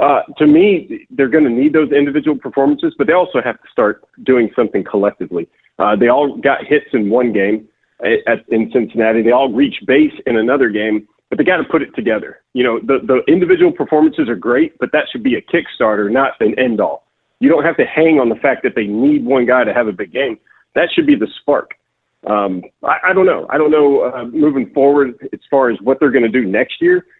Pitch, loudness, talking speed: 145 Hz, -14 LUFS, 235 wpm